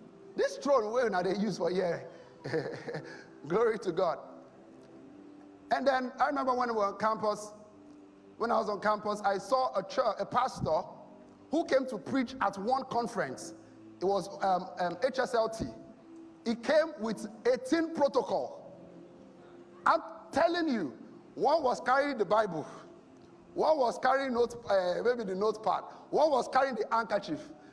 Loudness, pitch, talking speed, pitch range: -31 LUFS, 235 Hz, 150 wpm, 200-270 Hz